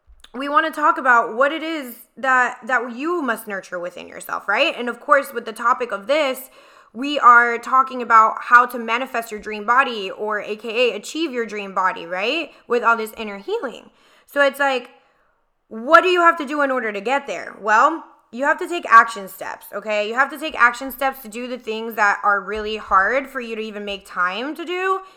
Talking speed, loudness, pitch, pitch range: 215 wpm, -19 LUFS, 245 Hz, 220-285 Hz